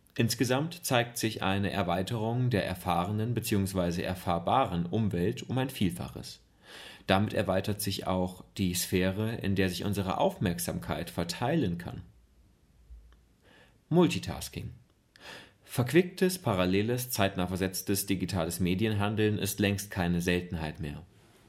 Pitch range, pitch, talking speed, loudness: 90-110 Hz, 95 Hz, 105 wpm, -30 LUFS